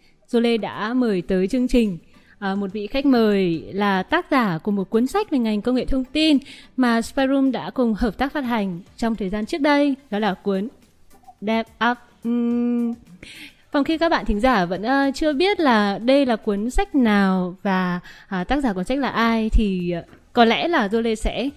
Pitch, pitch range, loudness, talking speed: 235 Hz, 205-265 Hz, -21 LUFS, 205 wpm